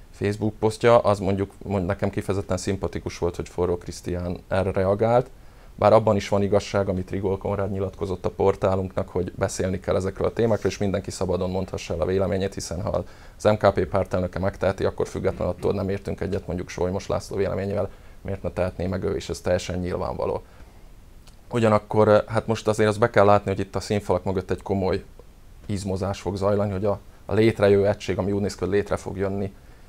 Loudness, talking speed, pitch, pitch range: -24 LUFS, 185 wpm, 100 Hz, 90-105 Hz